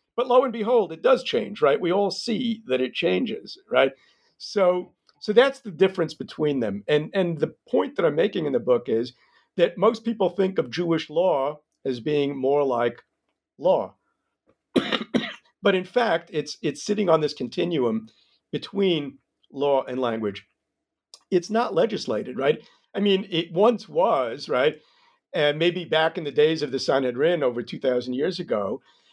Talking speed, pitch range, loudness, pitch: 165 wpm, 140-215 Hz, -24 LUFS, 175 Hz